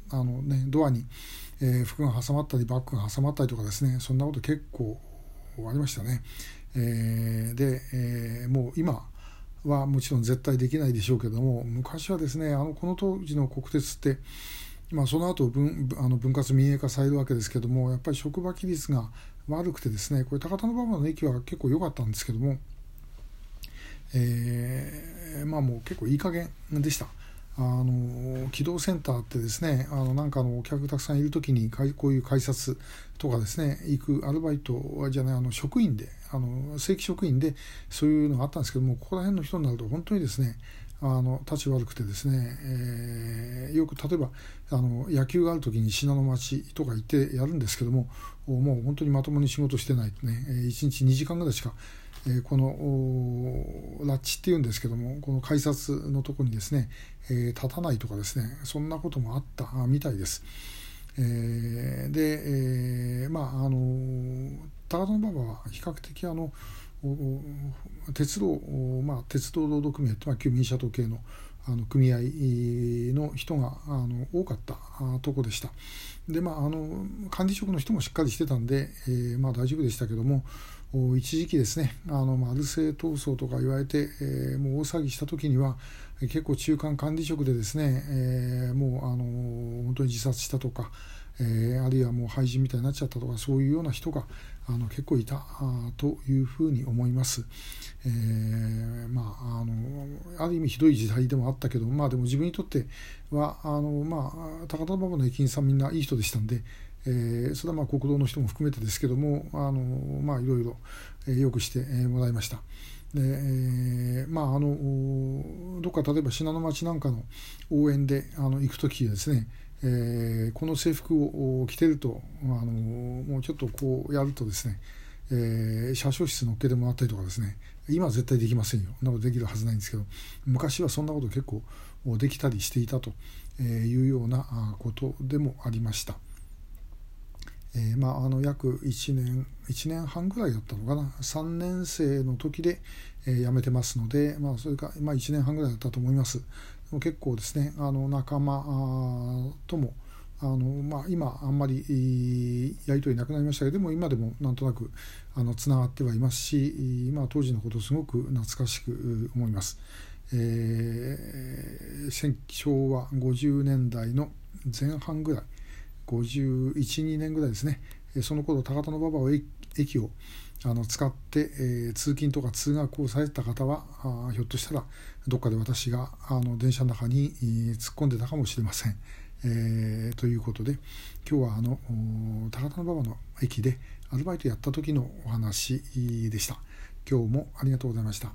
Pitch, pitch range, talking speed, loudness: 130 Hz, 120-145 Hz, 335 characters per minute, -29 LUFS